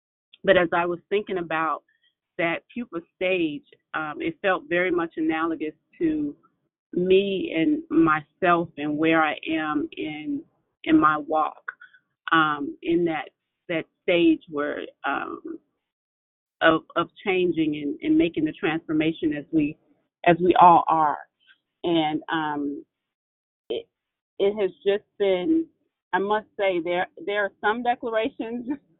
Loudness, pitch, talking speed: -24 LUFS, 195 Hz, 130 wpm